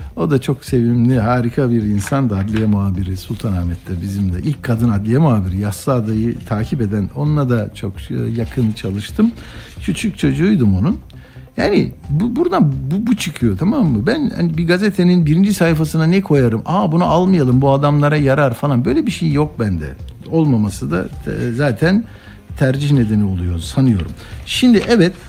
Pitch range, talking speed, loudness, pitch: 105-160 Hz, 155 wpm, -16 LUFS, 130 Hz